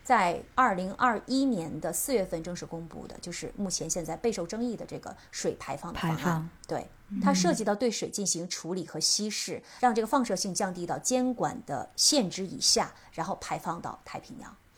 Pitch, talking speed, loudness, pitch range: 190 Hz, 290 characters per minute, -29 LUFS, 170-240 Hz